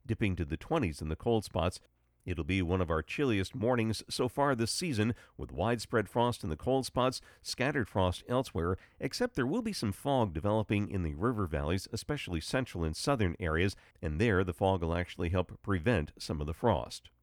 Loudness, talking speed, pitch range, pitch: -33 LUFS, 200 wpm, 90-120 Hz, 100 Hz